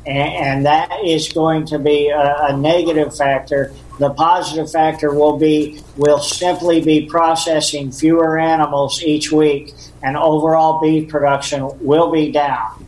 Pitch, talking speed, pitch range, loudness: 150 Hz, 135 wpm, 145-160 Hz, -15 LUFS